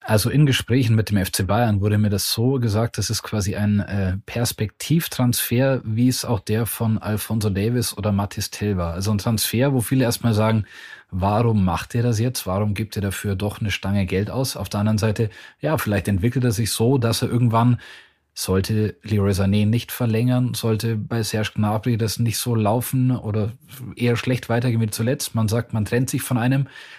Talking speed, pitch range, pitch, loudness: 195 wpm, 105-120 Hz, 110 Hz, -21 LUFS